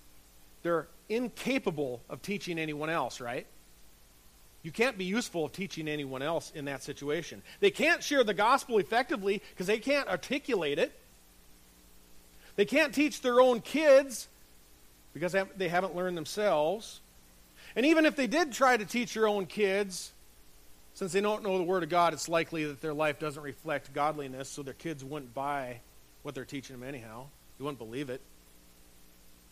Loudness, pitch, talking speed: -31 LUFS, 150 Hz, 170 wpm